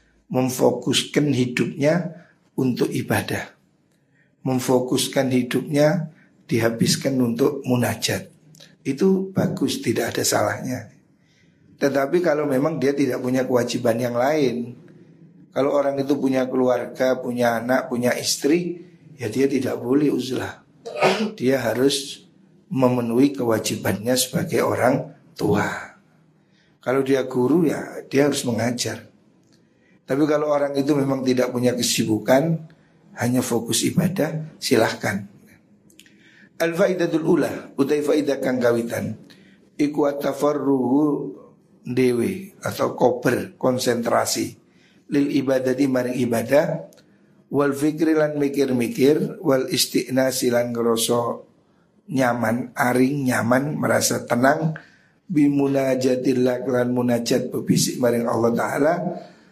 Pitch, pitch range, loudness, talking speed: 135 Hz, 125-150 Hz, -21 LUFS, 100 wpm